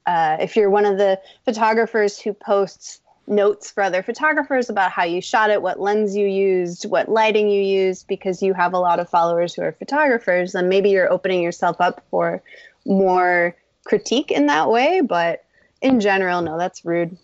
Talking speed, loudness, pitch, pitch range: 190 wpm, -19 LUFS, 195 Hz, 180-215 Hz